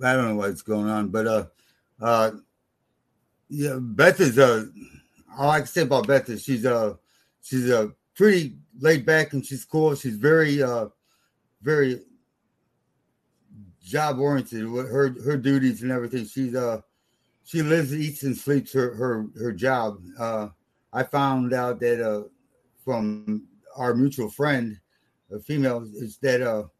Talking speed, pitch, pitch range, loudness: 150 wpm, 125 Hz, 110-140 Hz, -24 LUFS